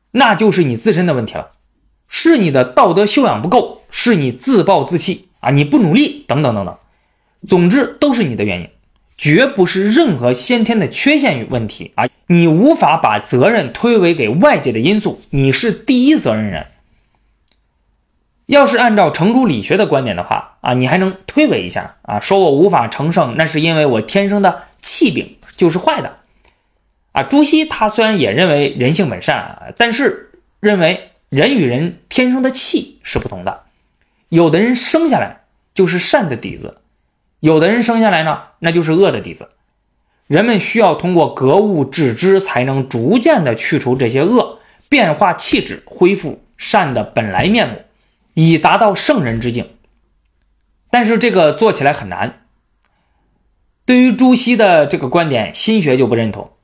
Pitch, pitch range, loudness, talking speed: 190 Hz, 140-235 Hz, -13 LUFS, 250 characters per minute